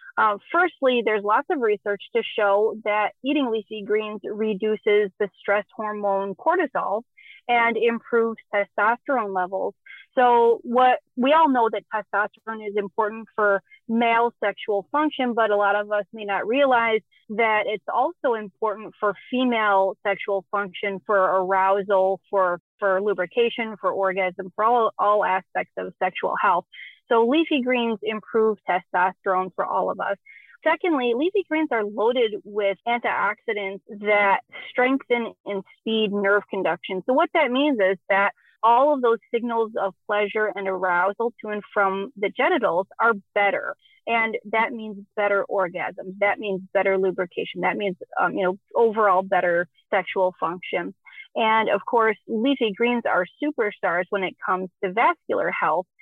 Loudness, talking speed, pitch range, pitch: -23 LUFS, 150 wpm, 195-235 Hz, 215 Hz